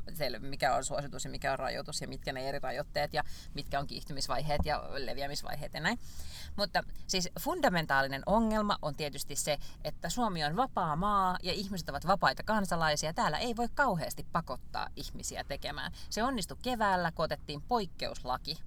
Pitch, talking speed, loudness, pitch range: 165 Hz, 160 wpm, -34 LUFS, 145-205 Hz